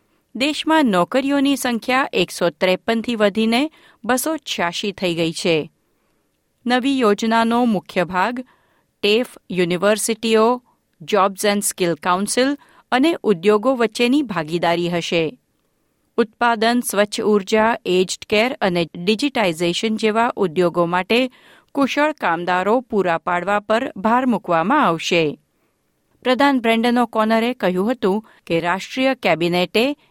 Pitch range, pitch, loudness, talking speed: 180-250 Hz, 220 Hz, -19 LUFS, 100 wpm